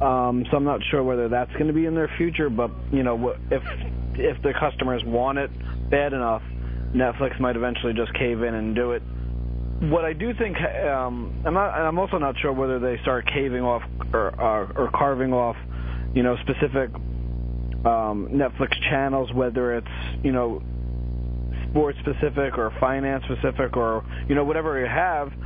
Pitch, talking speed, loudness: 125 Hz, 175 wpm, -24 LUFS